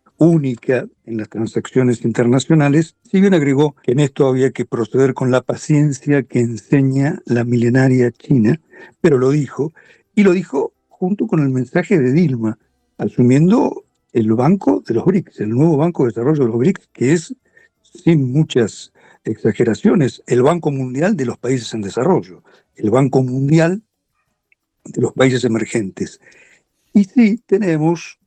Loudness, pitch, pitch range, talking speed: -16 LUFS, 140 Hz, 125-175 Hz, 150 wpm